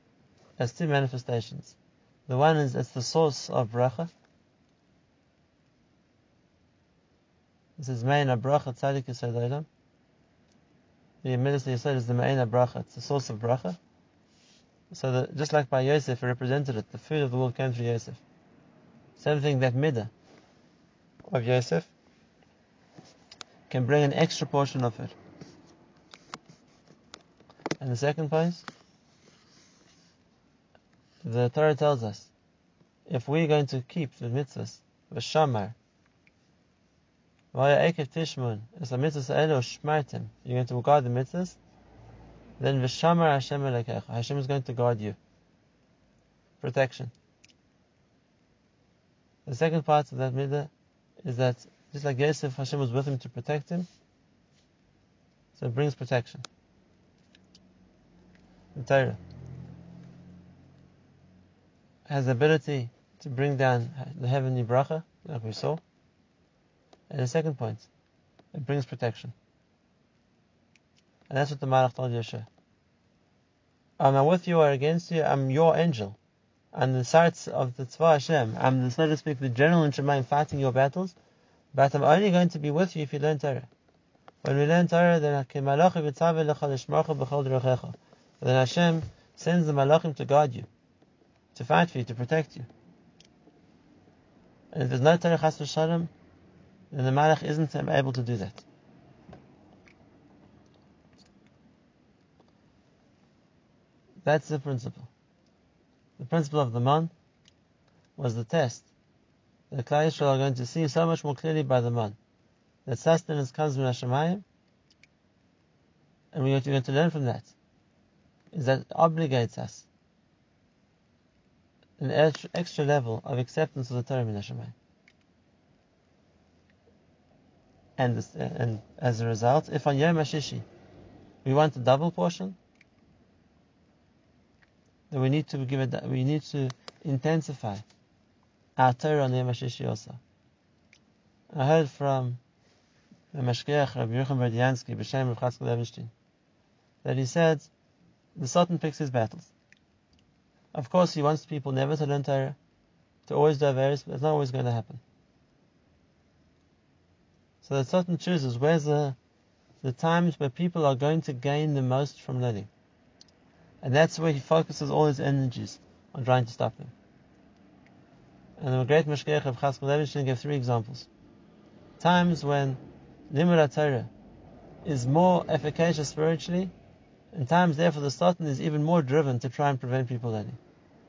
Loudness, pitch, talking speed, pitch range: -27 LUFS, 140 Hz, 130 wpm, 125-155 Hz